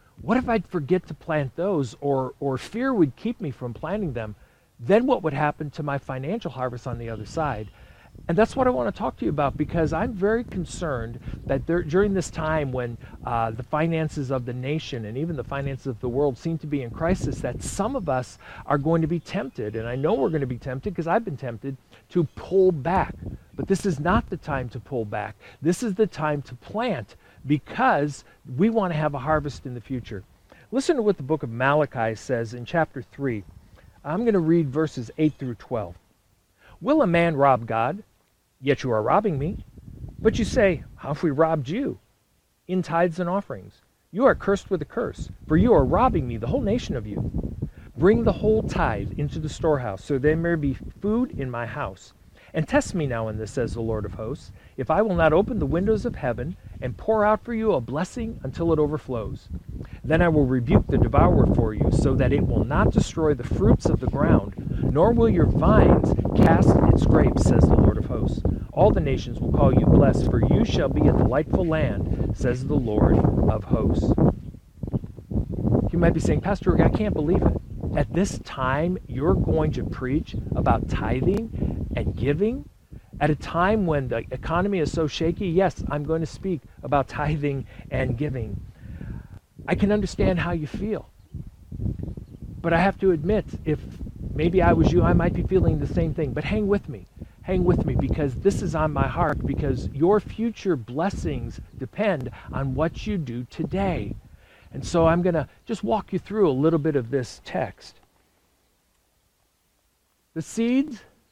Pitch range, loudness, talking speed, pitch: 125-175 Hz, -24 LUFS, 200 wpm, 150 Hz